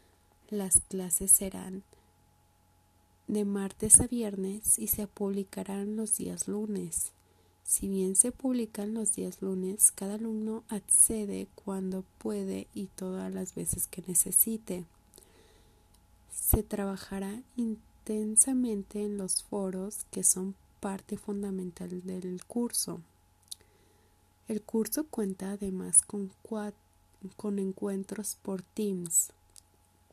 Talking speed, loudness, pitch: 105 wpm, -29 LUFS, 195 Hz